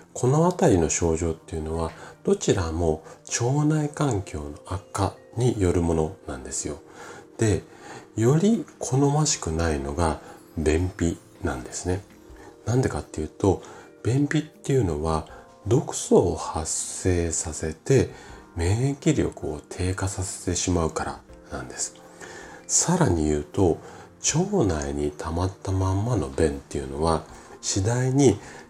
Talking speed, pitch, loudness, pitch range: 255 characters per minute, 90 Hz, -25 LUFS, 80-125 Hz